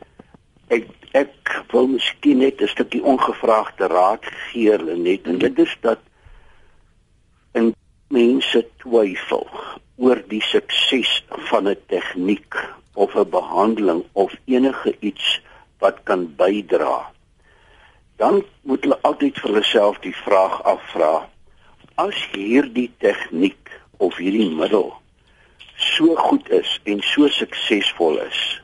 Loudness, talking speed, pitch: -19 LUFS, 120 wpm, 135 Hz